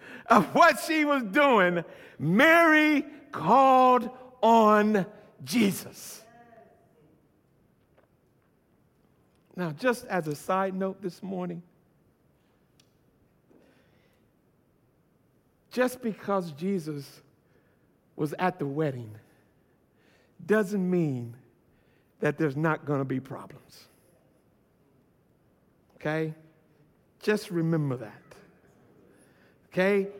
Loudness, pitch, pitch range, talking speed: -25 LUFS, 185 Hz, 155-225 Hz, 75 wpm